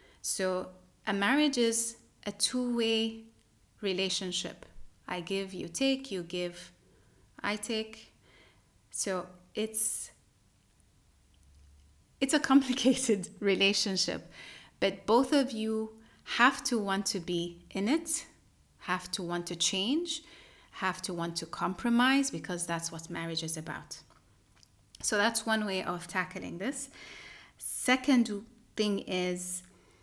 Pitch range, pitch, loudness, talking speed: 170-230 Hz, 195 Hz, -31 LUFS, 115 wpm